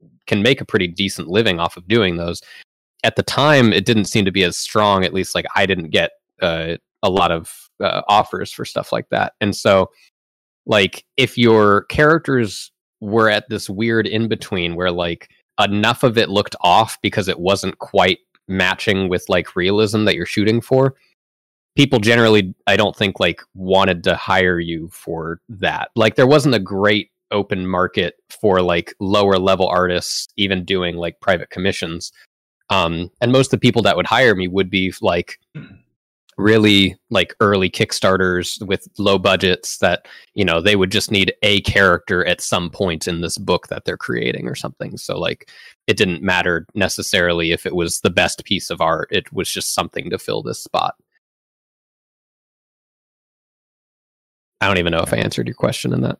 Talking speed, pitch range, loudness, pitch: 180 wpm, 90-110 Hz, -17 LUFS, 95 Hz